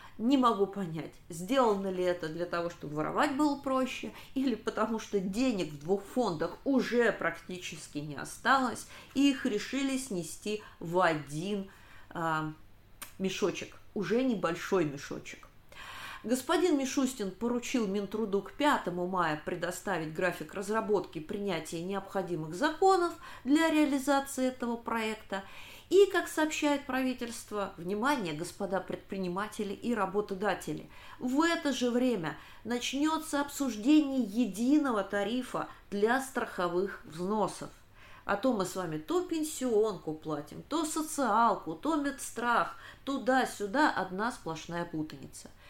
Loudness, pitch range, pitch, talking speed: -32 LUFS, 180-265 Hz, 210 Hz, 115 wpm